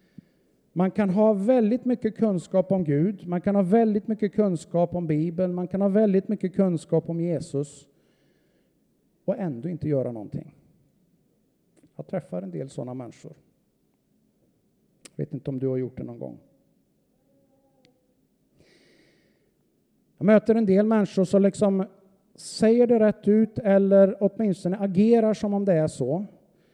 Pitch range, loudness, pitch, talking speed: 160-210 Hz, -24 LUFS, 195 Hz, 145 wpm